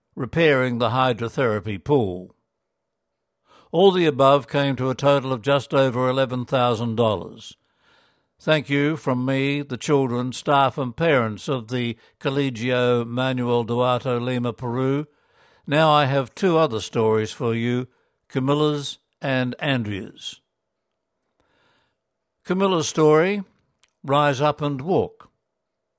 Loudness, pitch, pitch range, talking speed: -21 LUFS, 135 Hz, 125-145 Hz, 110 wpm